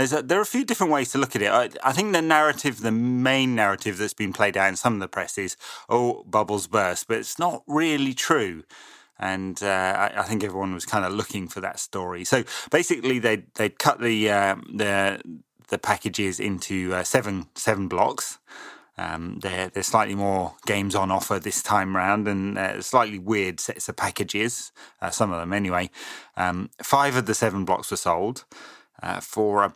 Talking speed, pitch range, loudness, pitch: 200 wpm, 95-125 Hz, -24 LUFS, 105 Hz